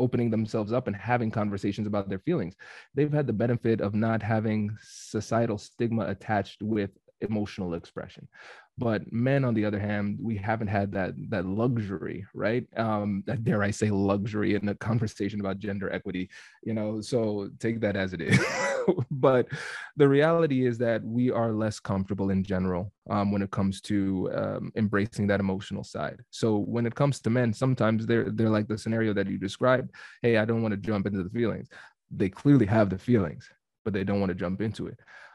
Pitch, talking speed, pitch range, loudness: 110 Hz, 190 wpm, 100-115 Hz, -28 LUFS